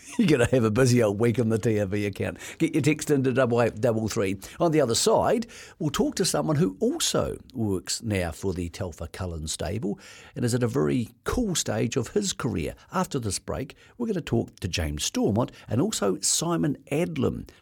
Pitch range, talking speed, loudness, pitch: 95-130 Hz, 200 wpm, -26 LUFS, 115 Hz